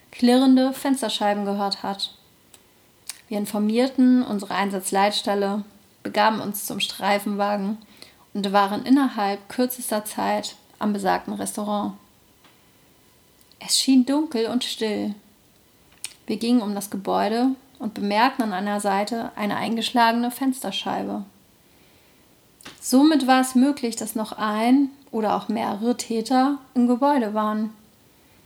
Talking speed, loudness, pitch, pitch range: 110 wpm, -22 LUFS, 220 Hz, 205-250 Hz